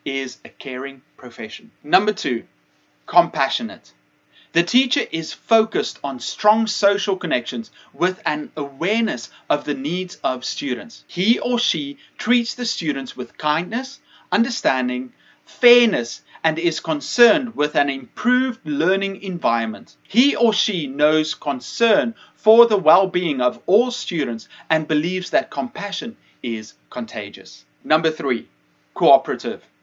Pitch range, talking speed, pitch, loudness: 145-225 Hz, 125 wpm, 175 Hz, -20 LUFS